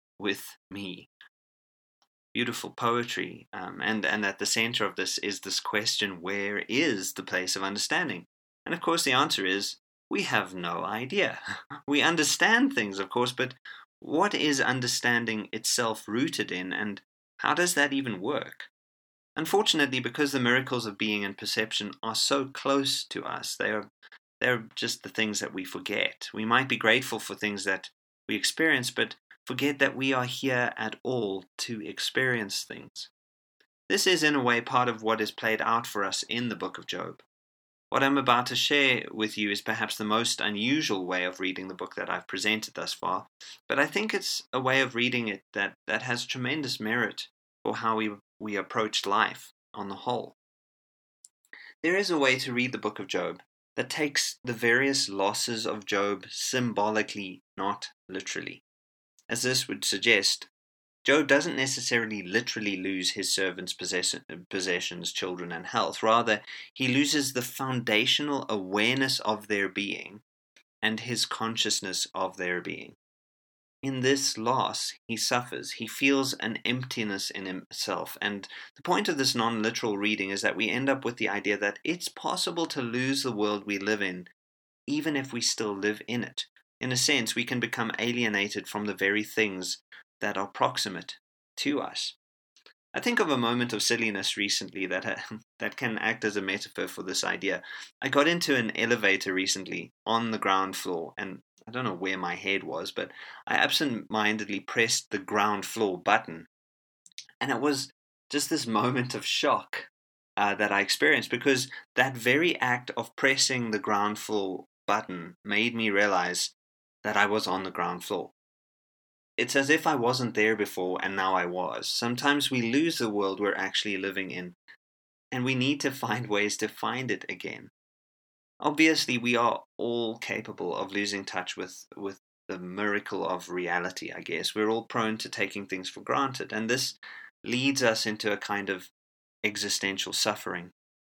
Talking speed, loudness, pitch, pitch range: 170 wpm, -28 LUFS, 110 Hz, 100-125 Hz